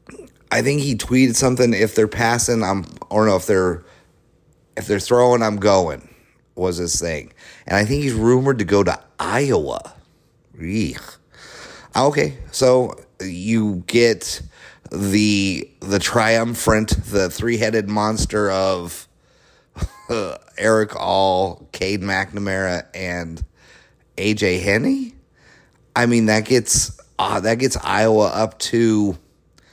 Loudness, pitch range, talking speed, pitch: -19 LUFS, 95-120 Hz, 120 wpm, 105 Hz